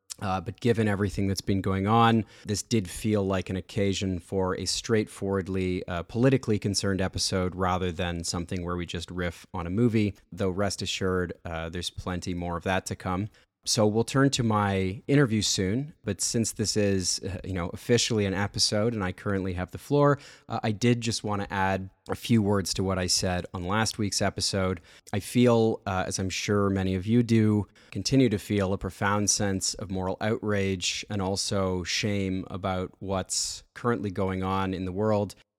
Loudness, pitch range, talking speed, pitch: -27 LUFS, 95-110 Hz, 190 wpm, 100 Hz